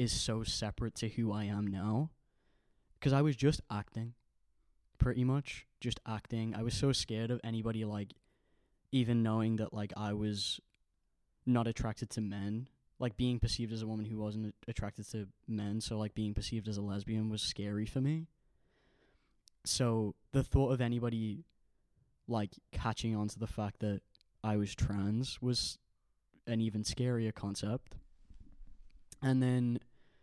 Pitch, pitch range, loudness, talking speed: 110 Hz, 105-120 Hz, -36 LUFS, 155 wpm